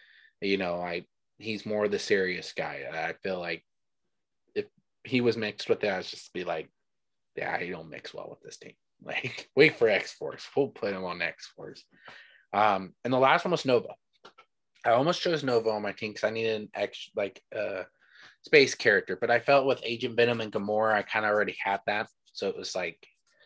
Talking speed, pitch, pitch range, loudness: 210 wpm, 115 Hz, 105-140 Hz, -28 LUFS